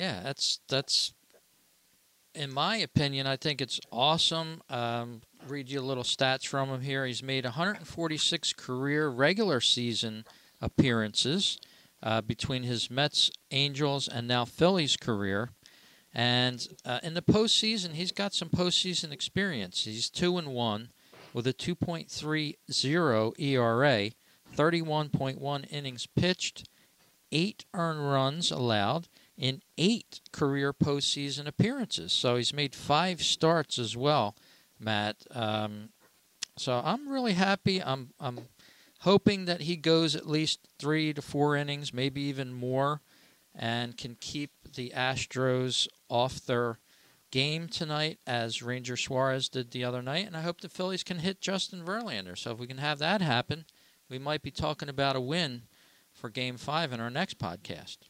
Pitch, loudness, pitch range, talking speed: 140 Hz, -30 LUFS, 125-165 Hz, 145 wpm